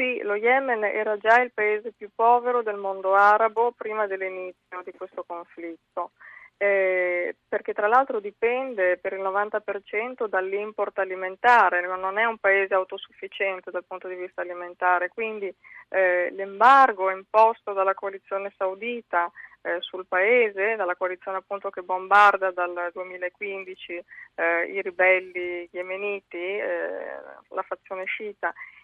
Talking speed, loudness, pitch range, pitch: 130 wpm, -24 LUFS, 185-215 Hz, 195 Hz